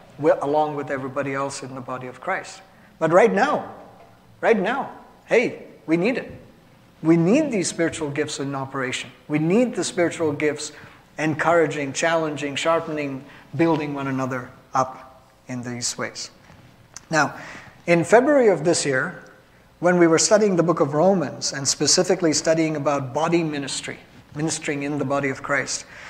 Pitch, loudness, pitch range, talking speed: 150 Hz, -22 LUFS, 135-165 Hz, 150 wpm